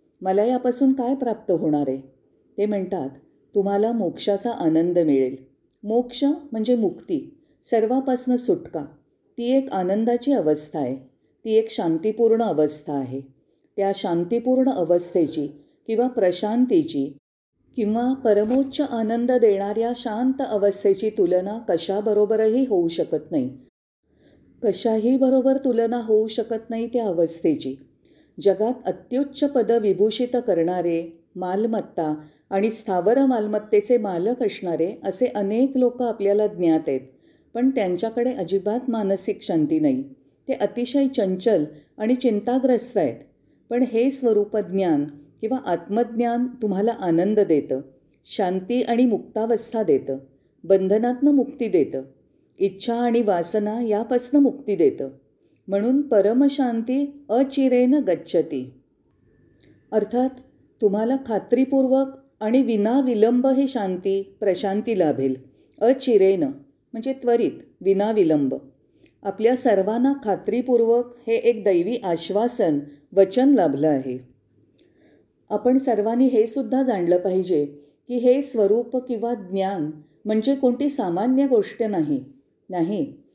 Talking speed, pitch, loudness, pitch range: 105 wpm, 220 Hz, -22 LUFS, 185-250 Hz